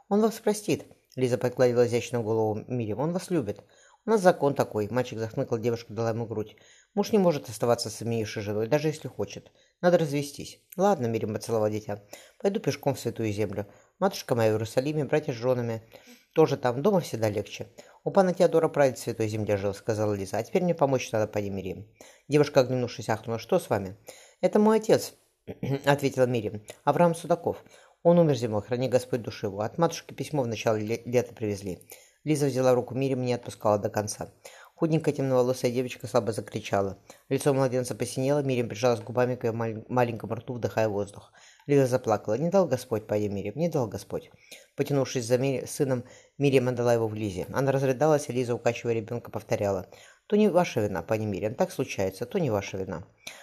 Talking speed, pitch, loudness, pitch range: 185 wpm, 125 Hz, -27 LUFS, 110-145 Hz